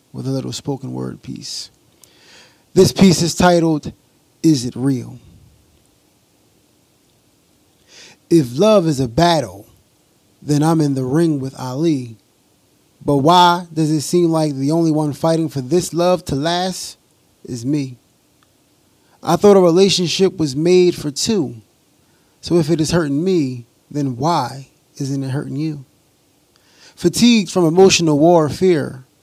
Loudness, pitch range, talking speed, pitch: -16 LUFS, 135-175 Hz, 135 wpm, 155 Hz